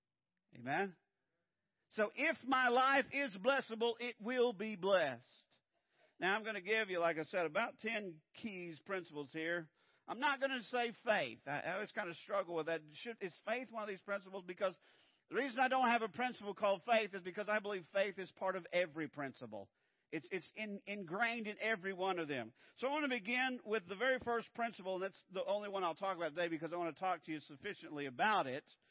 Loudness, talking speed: -39 LUFS, 215 wpm